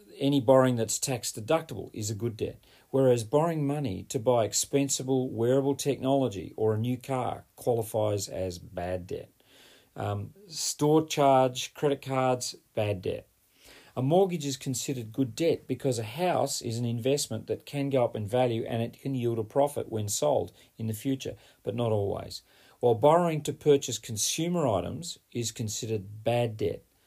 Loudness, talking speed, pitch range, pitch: -29 LUFS, 165 wpm, 110-140 Hz, 125 Hz